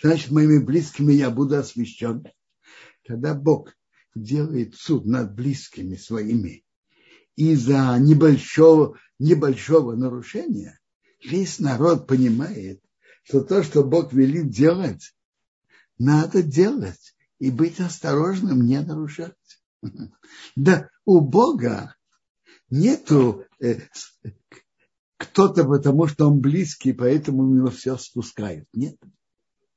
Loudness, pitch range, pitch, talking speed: -20 LUFS, 125-160 Hz, 145 Hz, 100 wpm